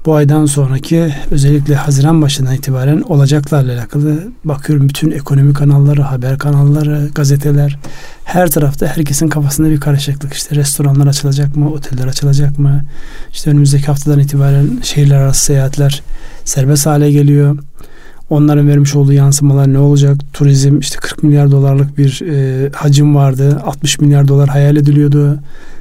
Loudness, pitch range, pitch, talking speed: -11 LUFS, 140-150 Hz, 145 Hz, 135 wpm